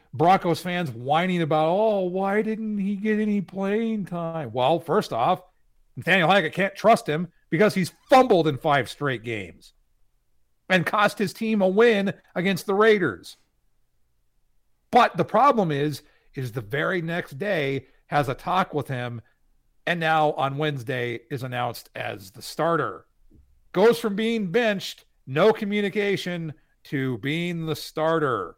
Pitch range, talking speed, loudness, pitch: 140-205 Hz, 145 wpm, -23 LUFS, 170 Hz